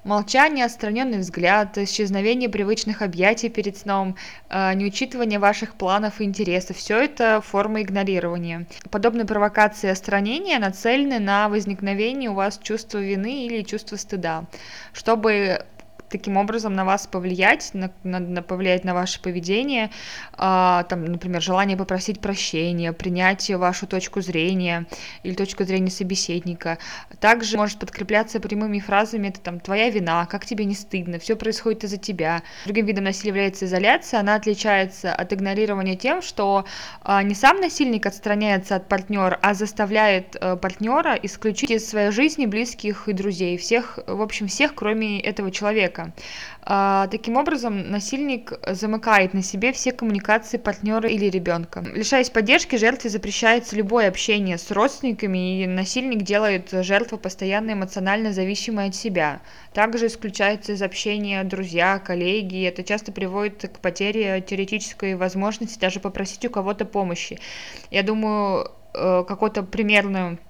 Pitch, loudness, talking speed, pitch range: 205 Hz, -22 LUFS, 135 wpm, 190-220 Hz